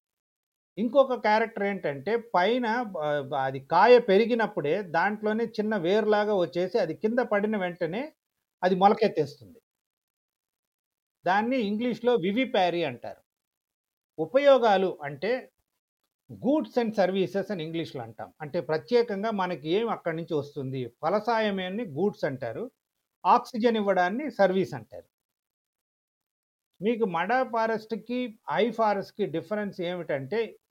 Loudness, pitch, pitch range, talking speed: -27 LUFS, 205 Hz, 175-230 Hz, 100 wpm